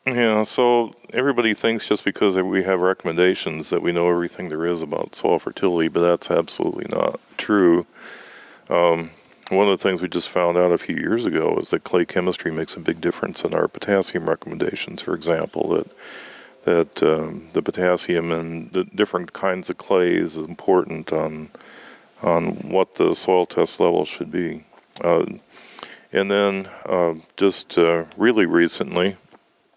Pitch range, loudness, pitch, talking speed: 85-95 Hz, -21 LUFS, 90 Hz, 160 wpm